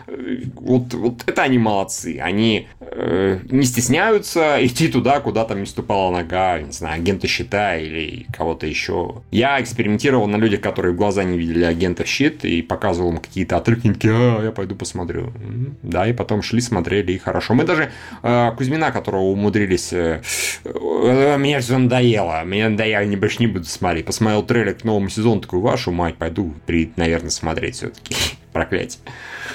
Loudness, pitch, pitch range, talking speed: -19 LUFS, 105 Hz, 90-120 Hz, 170 wpm